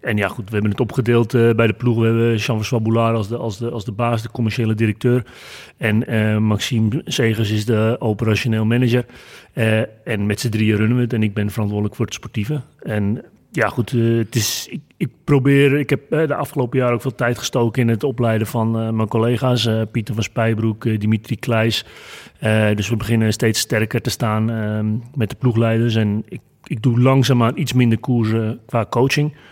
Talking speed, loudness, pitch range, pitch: 210 wpm, -19 LUFS, 110-125 Hz, 115 Hz